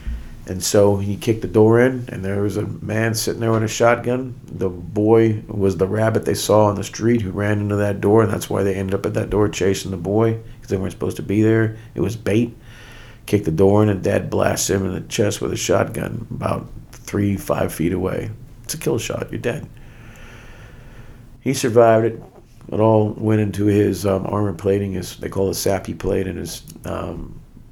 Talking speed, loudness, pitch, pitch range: 215 wpm, -19 LUFS, 110 Hz, 100-115 Hz